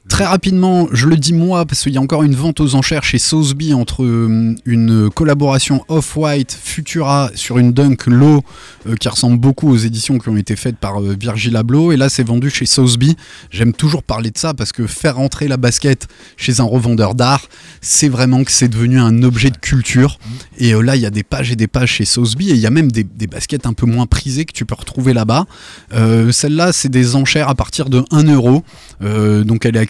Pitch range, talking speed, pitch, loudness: 115-145 Hz, 230 wpm, 125 Hz, -13 LUFS